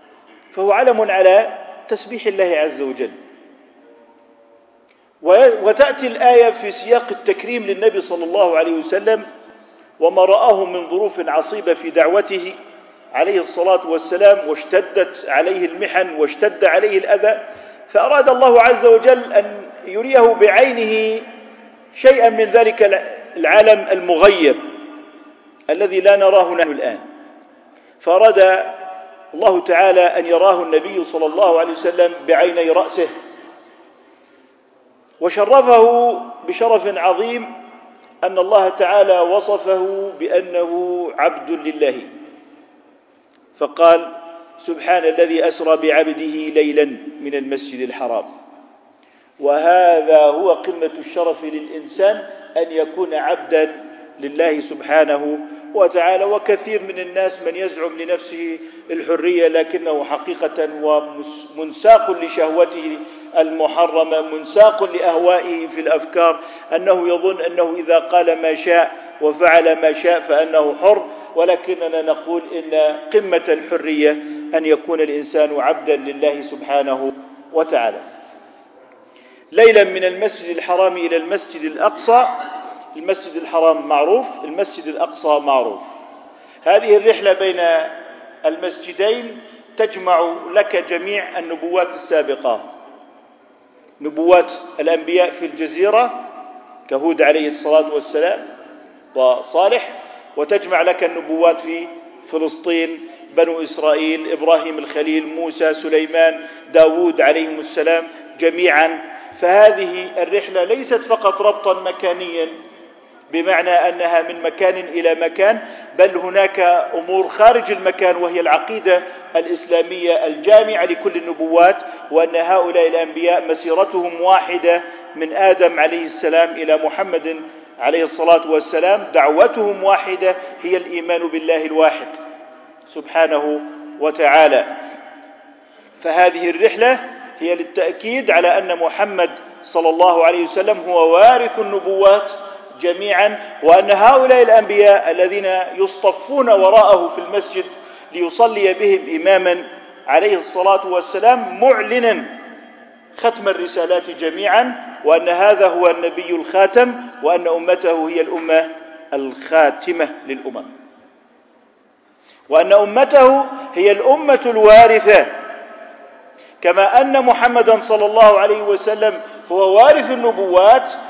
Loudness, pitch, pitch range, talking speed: -15 LUFS, 180 Hz, 165-225 Hz, 100 wpm